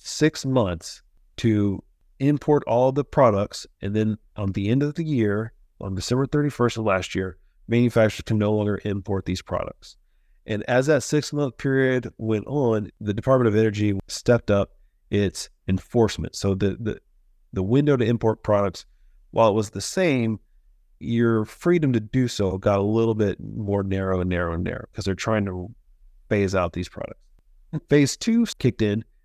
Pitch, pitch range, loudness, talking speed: 110 Hz, 95-125 Hz, -23 LUFS, 170 wpm